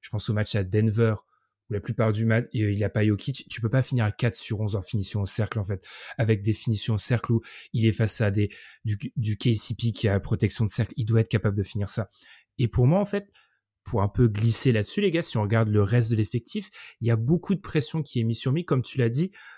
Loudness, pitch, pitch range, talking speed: -24 LUFS, 115 Hz, 105-125 Hz, 280 wpm